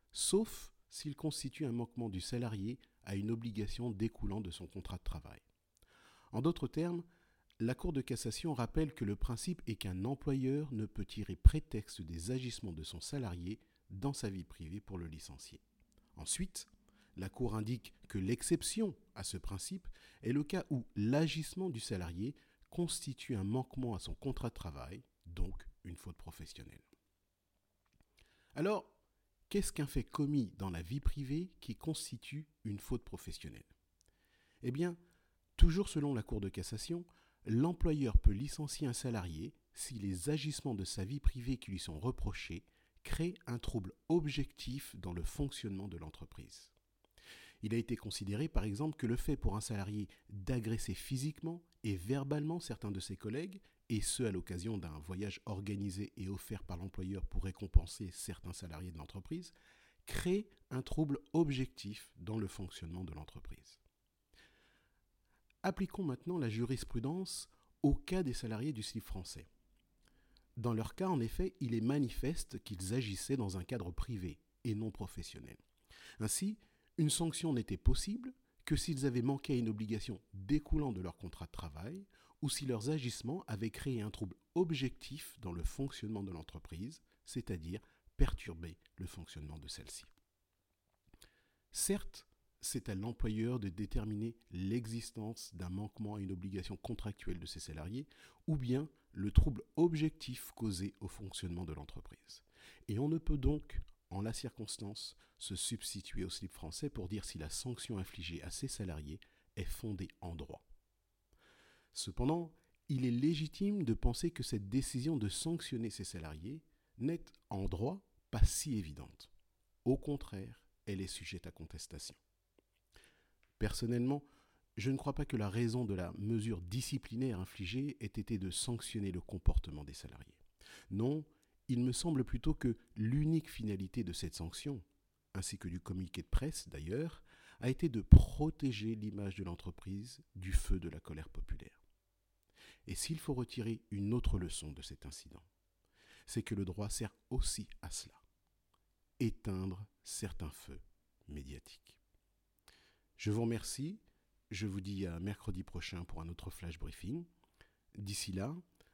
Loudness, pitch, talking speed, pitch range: -40 LUFS, 110 Hz, 150 wpm, 95-135 Hz